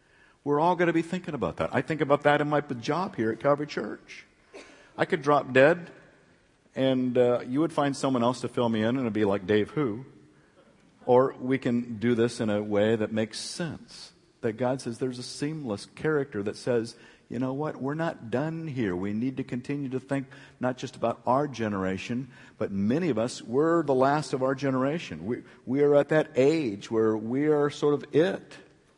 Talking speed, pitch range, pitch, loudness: 205 wpm, 120-145 Hz, 130 Hz, -27 LUFS